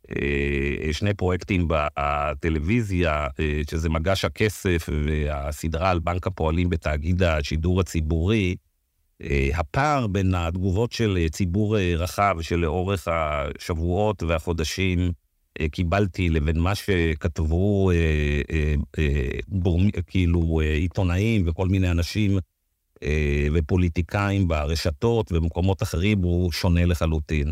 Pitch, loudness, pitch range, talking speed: 85 Hz, -24 LUFS, 80-95 Hz, 85 wpm